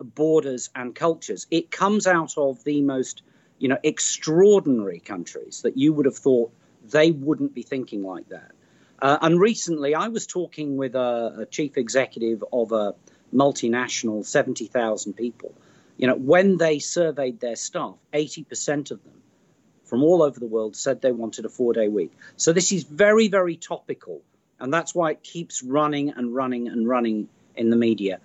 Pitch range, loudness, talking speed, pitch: 120-165 Hz, -23 LUFS, 170 wpm, 140 Hz